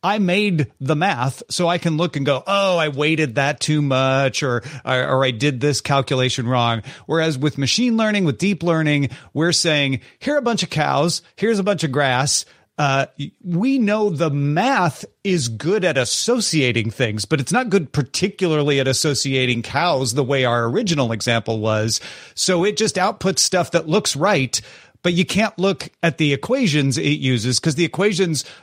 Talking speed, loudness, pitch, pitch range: 185 wpm, -19 LUFS, 150 Hz, 135-185 Hz